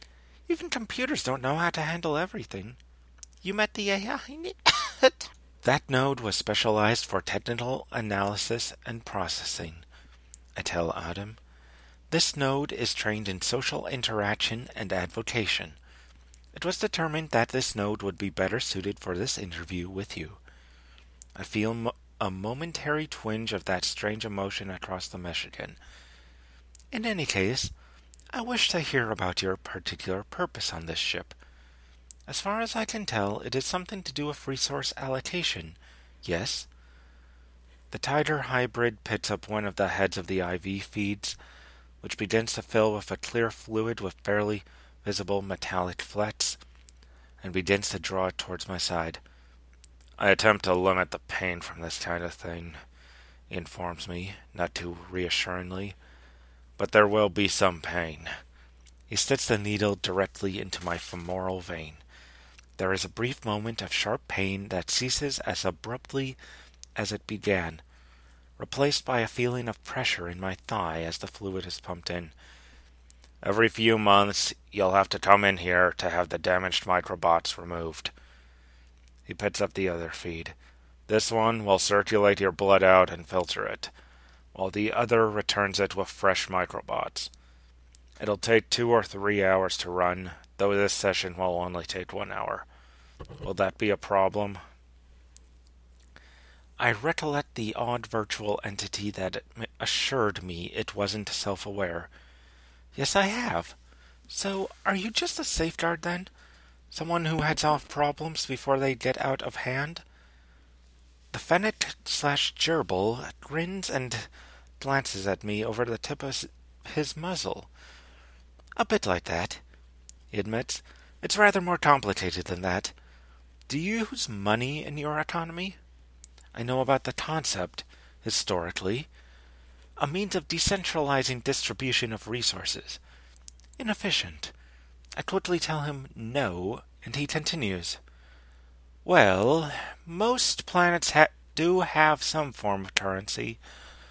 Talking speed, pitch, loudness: 145 wpm, 95 Hz, -28 LUFS